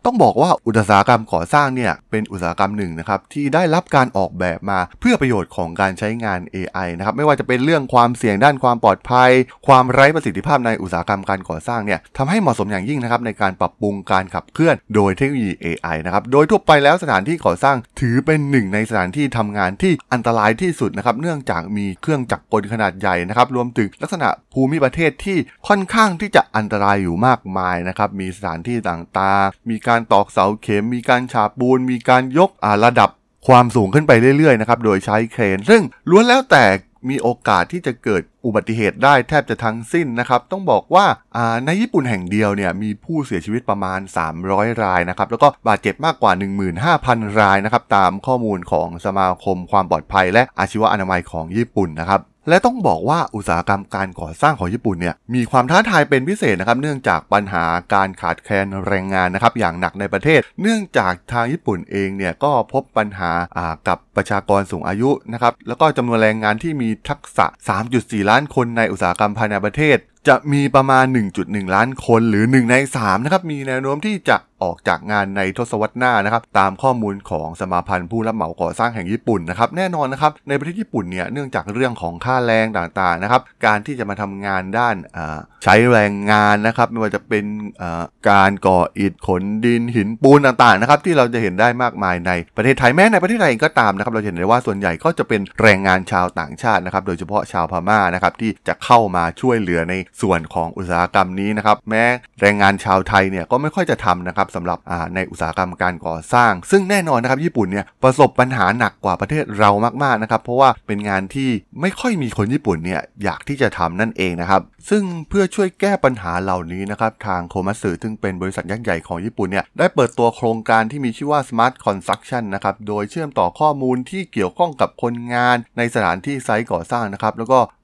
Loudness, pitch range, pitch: -17 LUFS, 95-130 Hz, 110 Hz